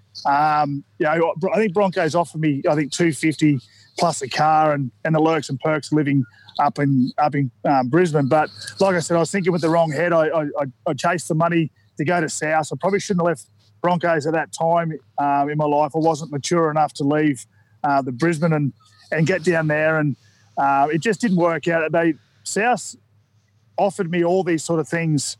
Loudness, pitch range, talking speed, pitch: -20 LUFS, 140-170 Hz, 215 wpm, 155 Hz